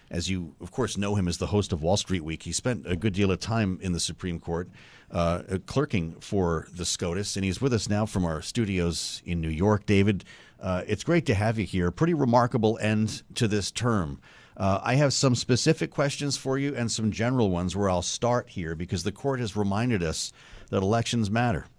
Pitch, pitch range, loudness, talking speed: 100 Hz, 90-120 Hz, -27 LUFS, 220 wpm